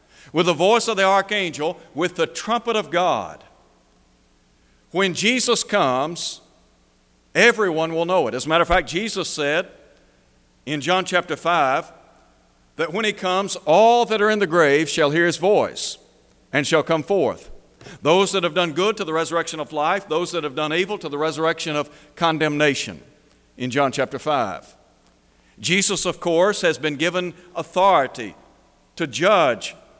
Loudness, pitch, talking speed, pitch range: -20 LUFS, 165 Hz, 160 wpm, 140-185 Hz